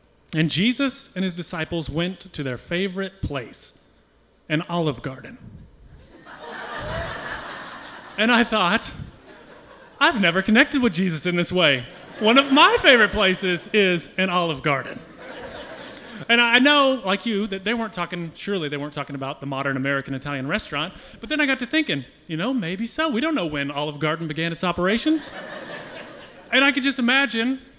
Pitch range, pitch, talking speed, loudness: 155-240 Hz, 185 Hz, 165 wpm, -21 LUFS